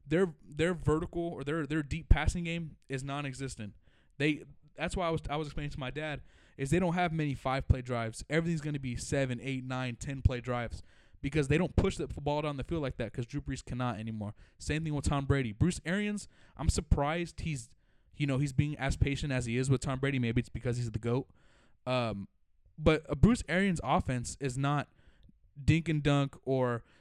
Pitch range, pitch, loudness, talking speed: 120-155 Hz, 140 Hz, -33 LUFS, 215 wpm